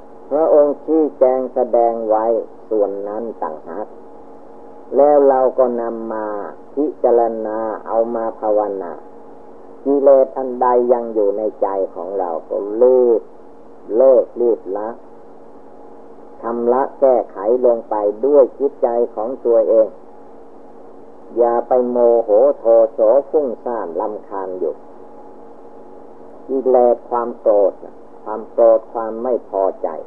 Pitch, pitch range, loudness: 115 Hz, 95-125 Hz, -16 LUFS